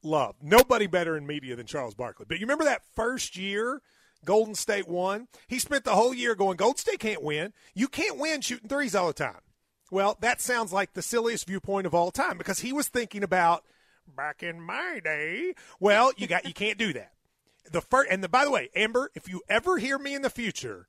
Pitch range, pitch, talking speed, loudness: 180-250 Hz, 215 Hz, 220 wpm, -27 LUFS